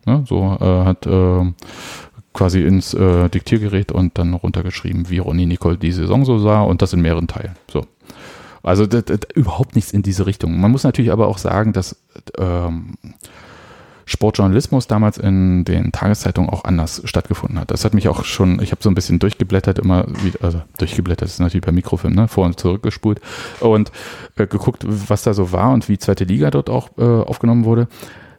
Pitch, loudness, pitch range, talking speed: 95 Hz, -17 LUFS, 90-110 Hz, 195 wpm